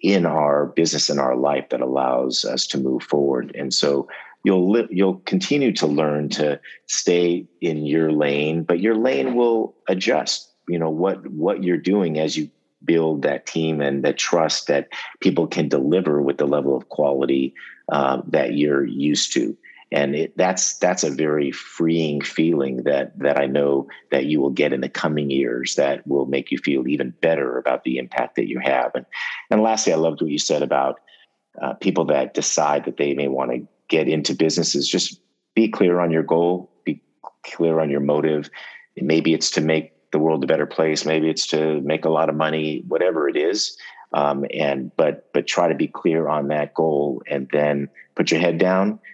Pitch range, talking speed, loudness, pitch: 70-80 Hz, 195 wpm, -21 LUFS, 75 Hz